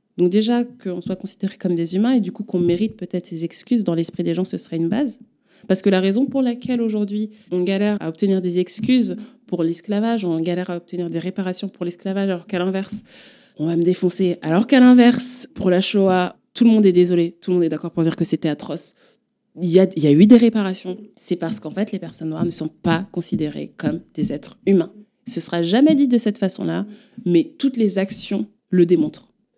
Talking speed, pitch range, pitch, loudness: 225 wpm, 175-220 Hz, 190 Hz, -19 LUFS